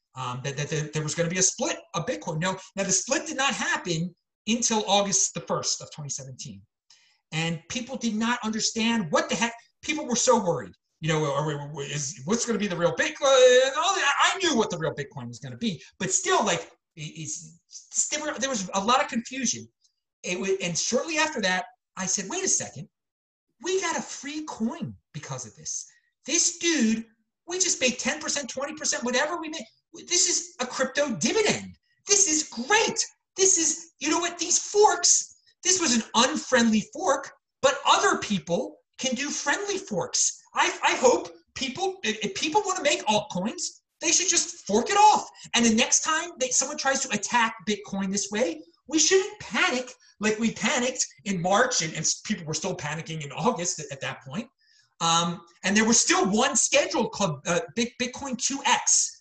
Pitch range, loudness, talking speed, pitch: 180-305 Hz, -24 LUFS, 185 wpm, 235 Hz